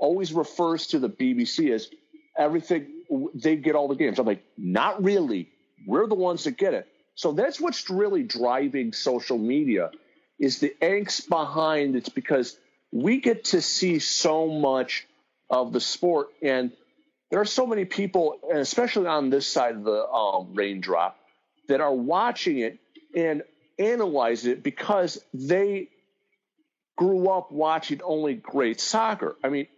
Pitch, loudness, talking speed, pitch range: 180 Hz, -25 LUFS, 155 wpm, 145-235 Hz